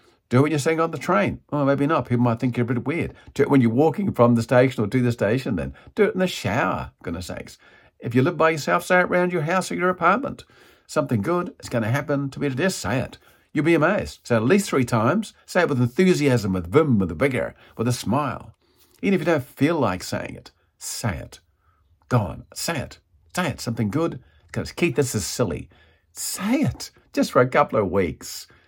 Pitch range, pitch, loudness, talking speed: 120-170 Hz, 140 Hz, -22 LUFS, 240 wpm